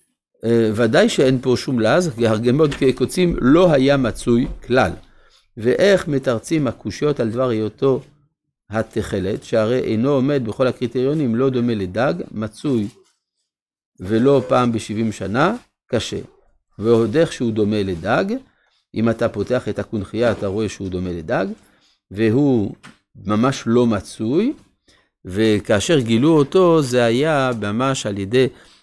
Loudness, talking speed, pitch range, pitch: -18 LUFS, 125 wpm, 110-140 Hz, 120 Hz